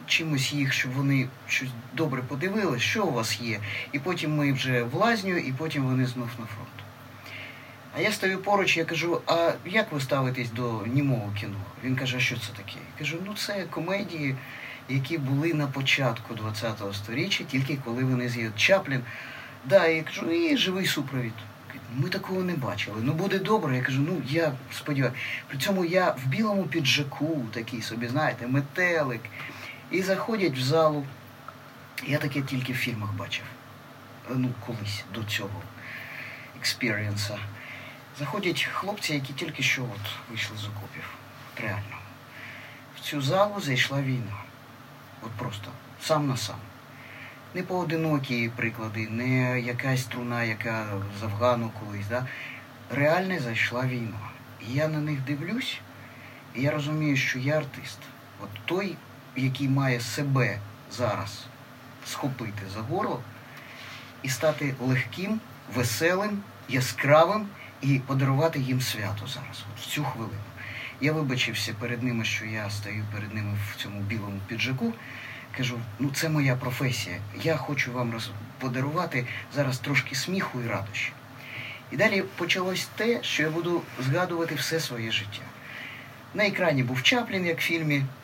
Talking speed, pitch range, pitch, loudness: 145 wpm, 120-150 Hz, 130 Hz, -28 LUFS